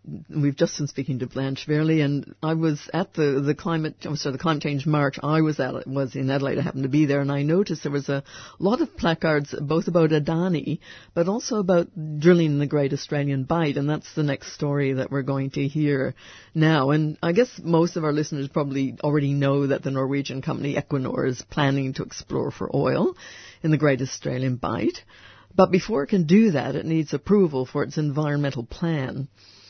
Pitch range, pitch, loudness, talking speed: 140-160 Hz, 145 Hz, -24 LUFS, 205 wpm